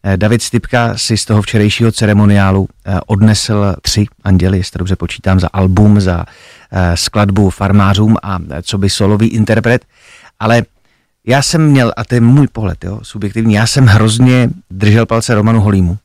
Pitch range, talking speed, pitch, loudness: 95-115 Hz, 155 wpm, 105 Hz, -11 LUFS